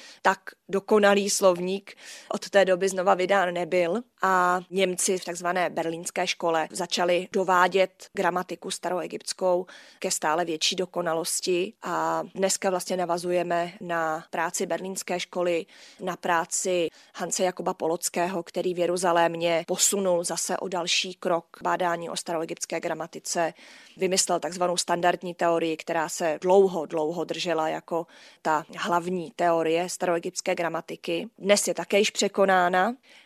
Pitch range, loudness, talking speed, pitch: 170-190 Hz, -26 LUFS, 125 wpm, 180 Hz